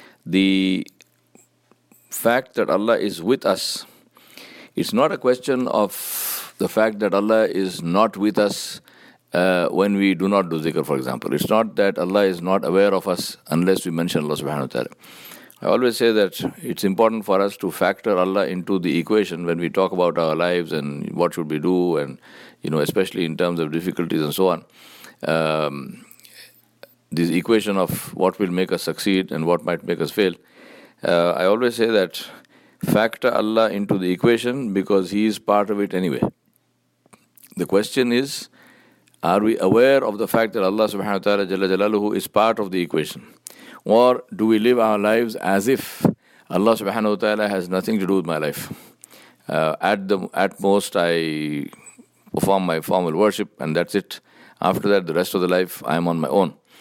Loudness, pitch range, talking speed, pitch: -20 LUFS, 85-105 Hz, 185 wpm, 95 Hz